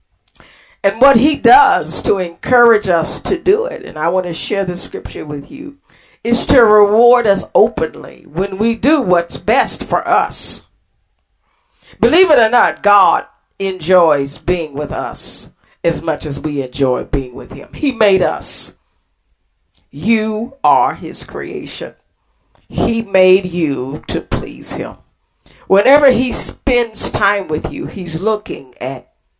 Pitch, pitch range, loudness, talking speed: 185 Hz, 155-235 Hz, -14 LUFS, 145 wpm